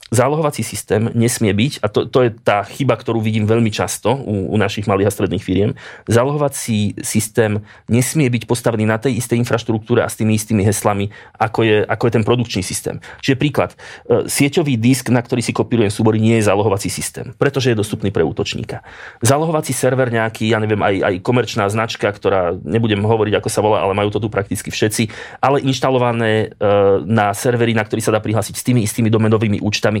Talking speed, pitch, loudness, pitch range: 190 wpm, 115 Hz, -17 LUFS, 105-125 Hz